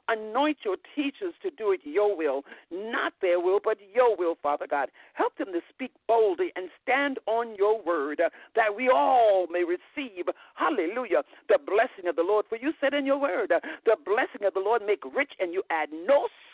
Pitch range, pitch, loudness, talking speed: 200-295 Hz, 230 Hz, -27 LUFS, 195 wpm